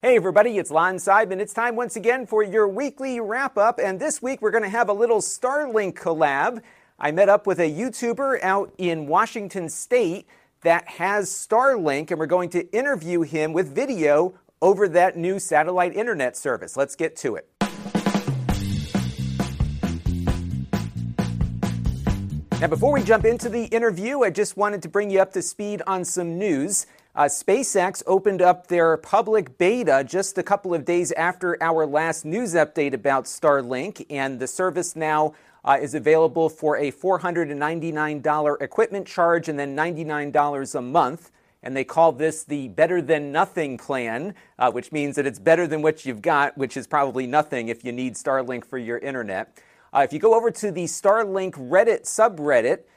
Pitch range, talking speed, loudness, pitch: 145-205 Hz, 170 wpm, -22 LUFS, 170 Hz